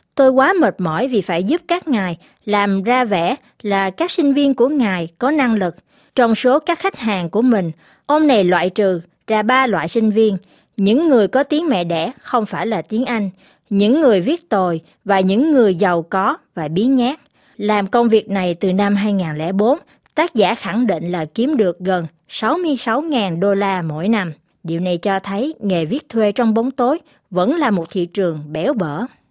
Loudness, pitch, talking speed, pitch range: -17 LUFS, 210 Hz, 200 wpm, 185-260 Hz